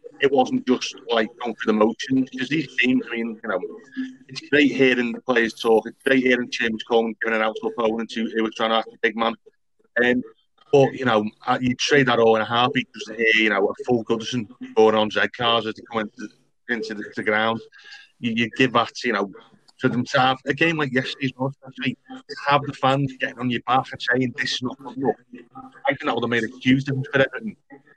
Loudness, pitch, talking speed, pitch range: -22 LUFS, 125 Hz, 240 wpm, 115-135 Hz